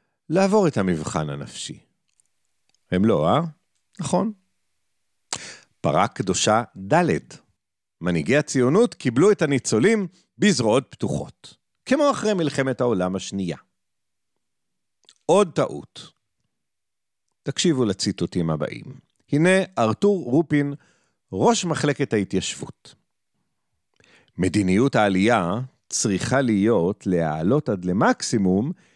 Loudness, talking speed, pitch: -22 LUFS, 85 wpm, 140 Hz